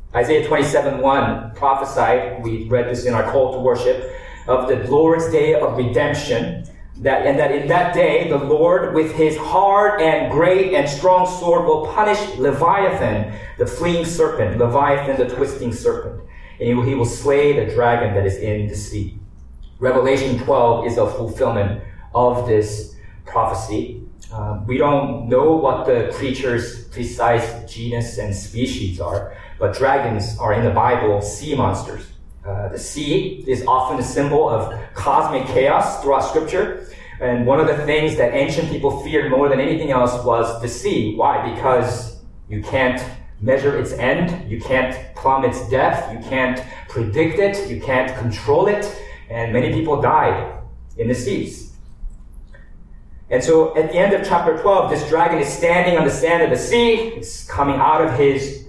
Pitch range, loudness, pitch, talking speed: 115-160 Hz, -18 LUFS, 130 Hz, 165 wpm